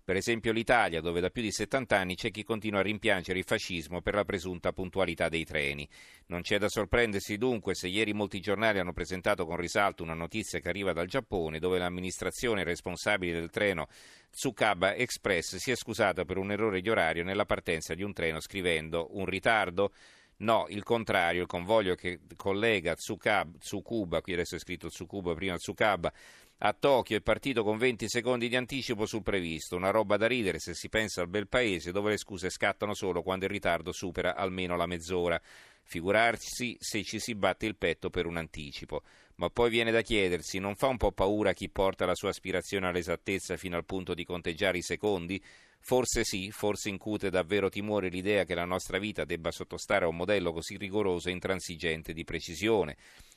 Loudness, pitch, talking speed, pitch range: -31 LUFS, 95 Hz, 190 wpm, 90-105 Hz